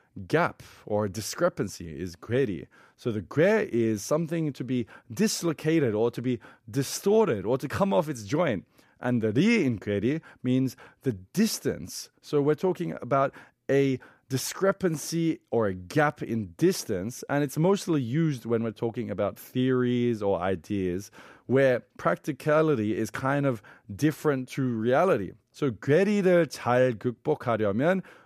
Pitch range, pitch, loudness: 115-155 Hz, 130 Hz, -27 LUFS